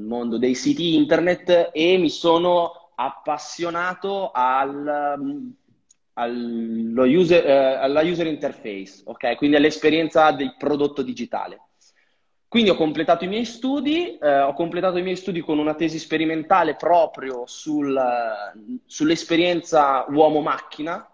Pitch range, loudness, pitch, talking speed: 135-175 Hz, -21 LUFS, 155 Hz, 105 wpm